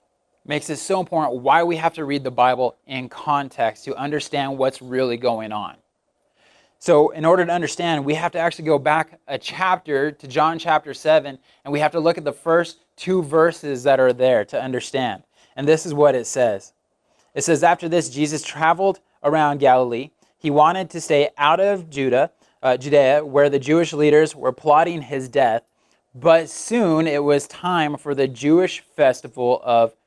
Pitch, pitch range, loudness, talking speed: 150 Hz, 135-165 Hz, -19 LUFS, 185 wpm